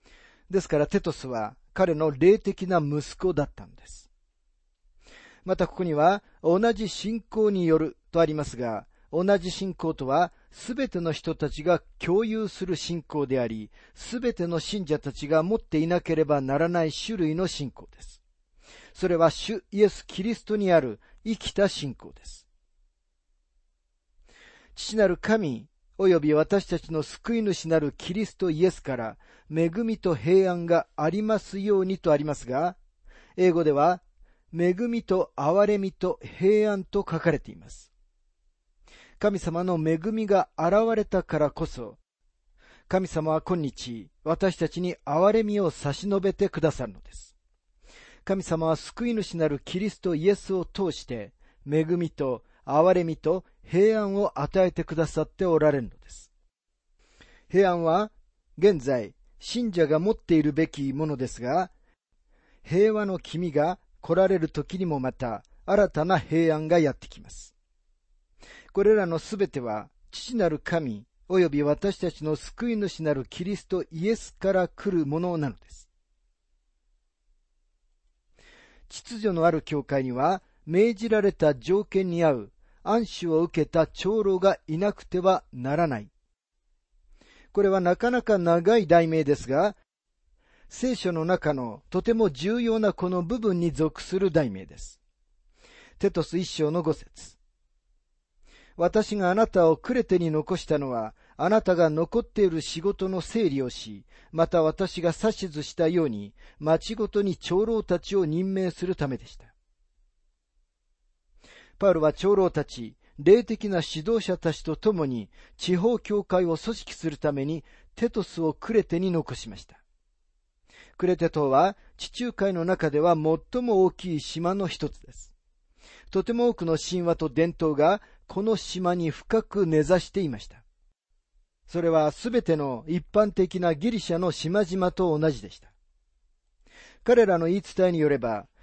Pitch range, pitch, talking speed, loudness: 145-195 Hz, 165 Hz, 265 characters per minute, -26 LUFS